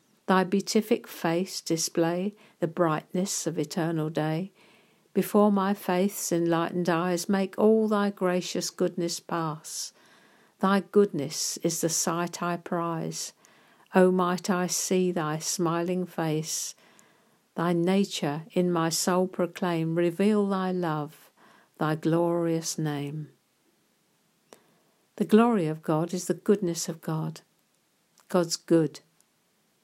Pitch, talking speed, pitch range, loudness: 175 Hz, 115 wpm, 165-190 Hz, -27 LUFS